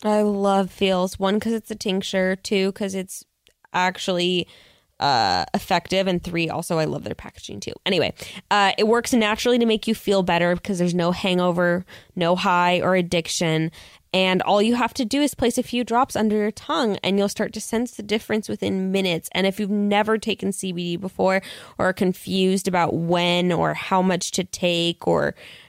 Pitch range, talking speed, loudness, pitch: 180-210 Hz, 190 wpm, -22 LUFS, 190 Hz